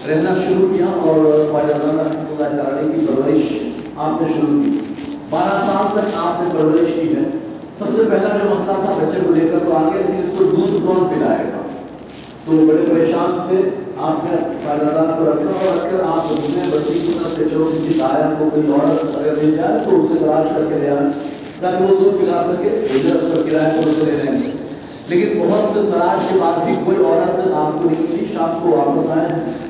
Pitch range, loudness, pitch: 155-200 Hz, -16 LUFS, 165 Hz